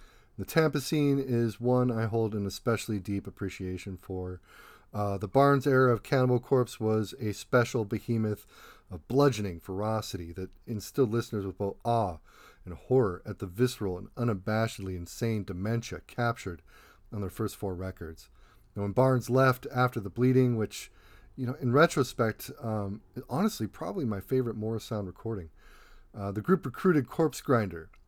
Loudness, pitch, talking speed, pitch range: -30 LUFS, 110 Hz, 155 wpm, 100-125 Hz